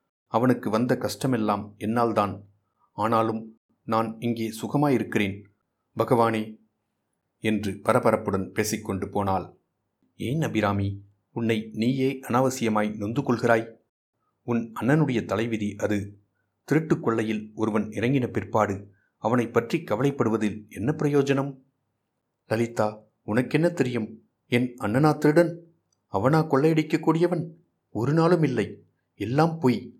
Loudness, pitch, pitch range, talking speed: -25 LUFS, 115 Hz, 105-130 Hz, 90 wpm